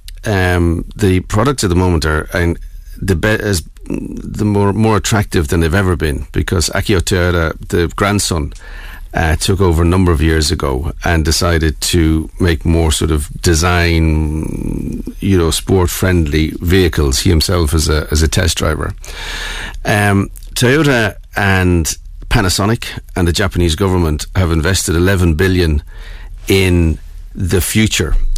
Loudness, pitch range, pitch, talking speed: -14 LUFS, 80-95 Hz, 90 Hz, 145 wpm